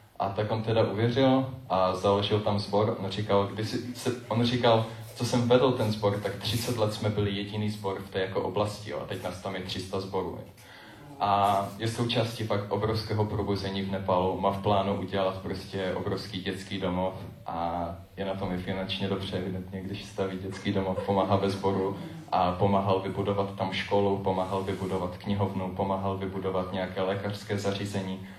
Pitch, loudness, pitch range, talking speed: 100 Hz, -29 LUFS, 95-105 Hz, 165 wpm